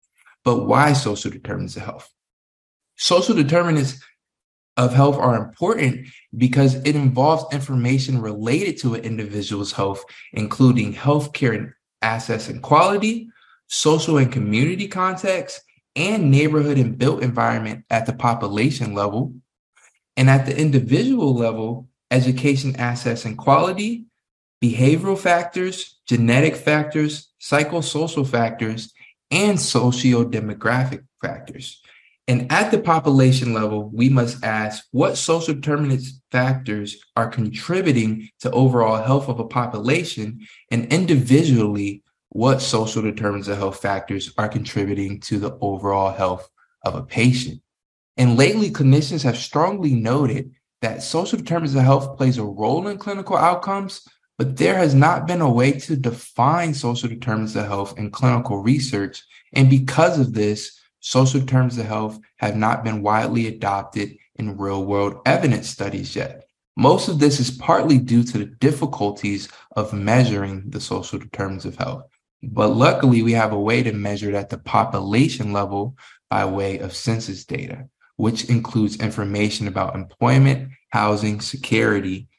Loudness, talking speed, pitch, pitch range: -20 LUFS, 135 wpm, 125 Hz, 110-140 Hz